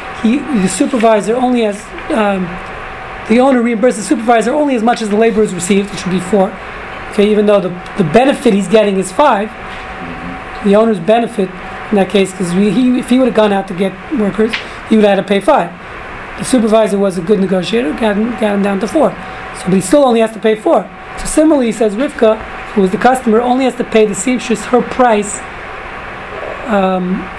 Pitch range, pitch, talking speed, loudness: 200-240 Hz, 220 Hz, 210 wpm, -12 LUFS